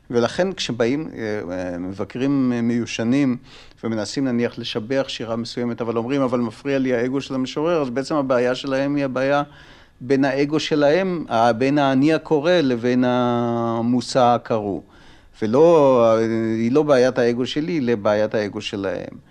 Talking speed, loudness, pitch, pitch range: 125 wpm, -20 LUFS, 125 Hz, 115-140 Hz